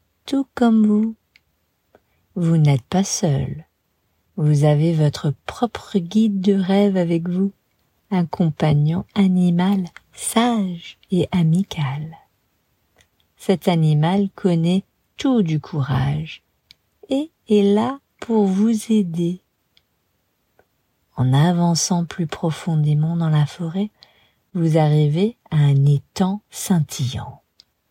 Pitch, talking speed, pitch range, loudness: 170 Hz, 100 wpm, 150-200 Hz, -19 LUFS